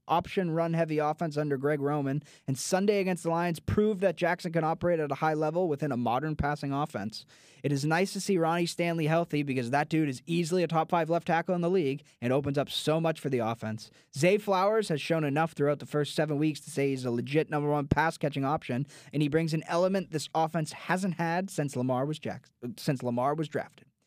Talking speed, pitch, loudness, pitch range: 230 wpm, 155 Hz, -29 LUFS, 140-170 Hz